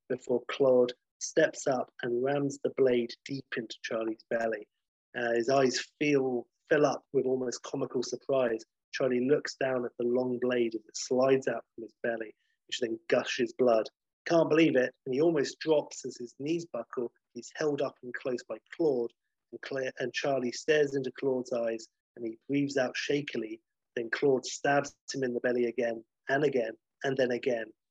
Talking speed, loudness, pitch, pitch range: 180 wpm, -31 LUFS, 130 Hz, 120-140 Hz